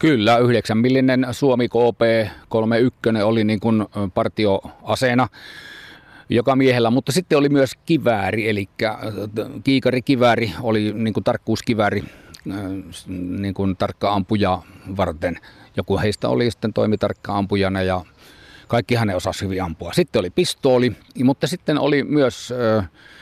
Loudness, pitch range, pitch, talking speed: -20 LUFS, 100-125 Hz, 110 Hz, 115 wpm